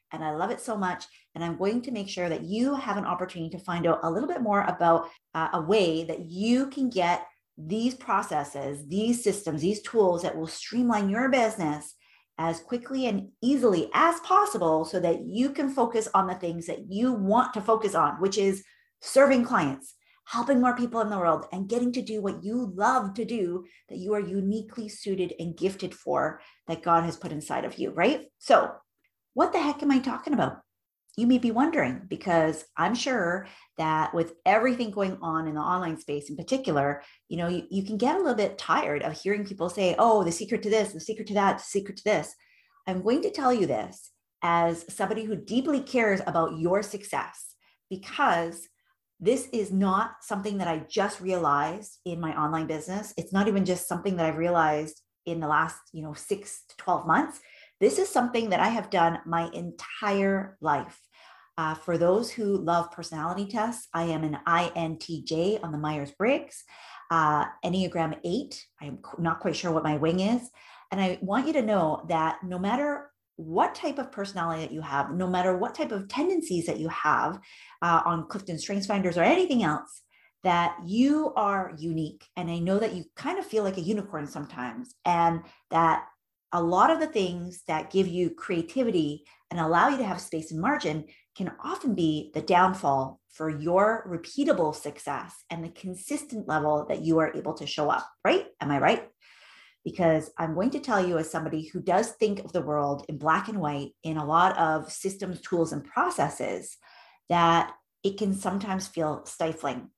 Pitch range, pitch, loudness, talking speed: 165-220 Hz, 185 Hz, -27 LUFS, 195 wpm